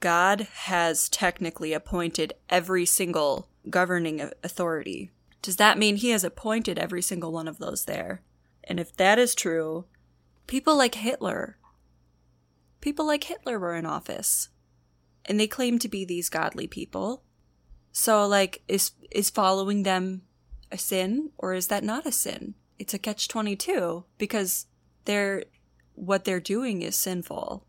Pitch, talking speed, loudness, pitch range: 185 Hz, 145 wpm, -26 LUFS, 165-210 Hz